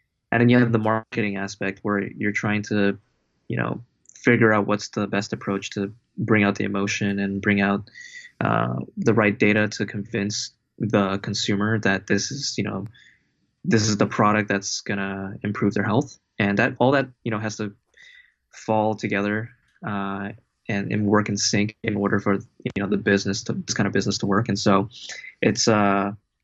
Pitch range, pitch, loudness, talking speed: 100-110 Hz, 105 Hz, -23 LUFS, 190 wpm